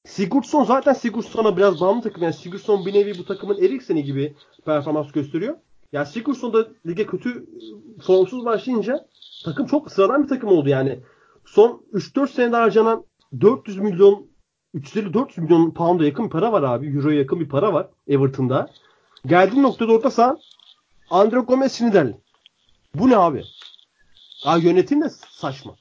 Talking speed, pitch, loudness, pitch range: 145 wpm, 205 Hz, -19 LUFS, 160-250 Hz